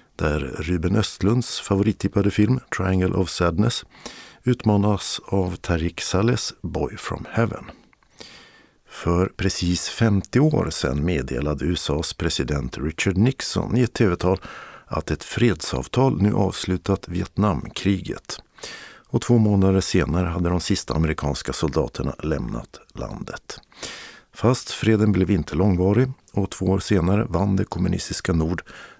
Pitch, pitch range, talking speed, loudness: 95 Hz, 85-105 Hz, 120 wpm, -22 LUFS